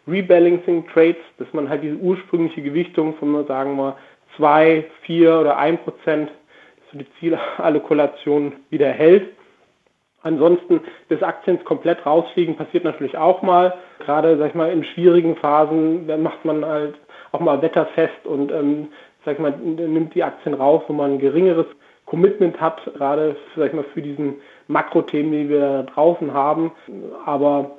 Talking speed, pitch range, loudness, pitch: 160 wpm, 145-165 Hz, -18 LUFS, 155 Hz